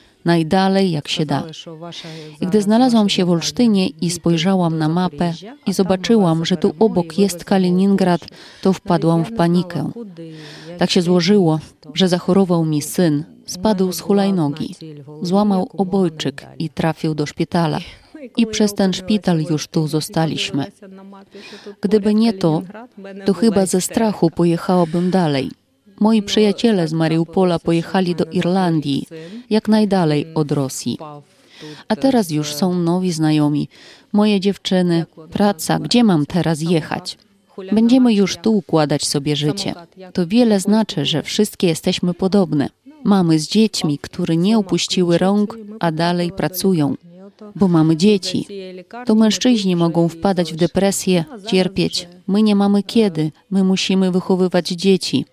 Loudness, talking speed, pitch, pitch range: -17 LUFS, 130 wpm, 185 Hz, 165-200 Hz